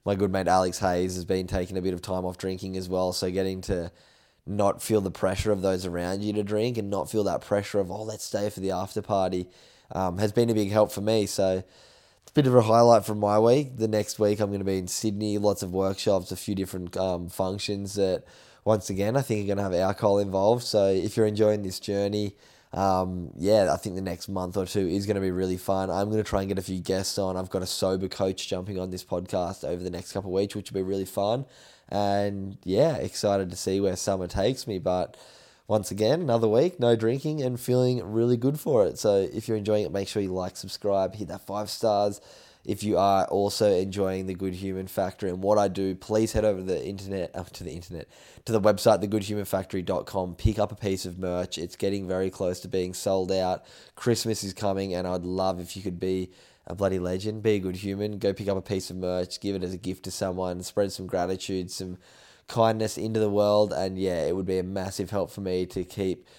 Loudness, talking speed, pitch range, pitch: -27 LUFS, 240 wpm, 95-105 Hz, 95 Hz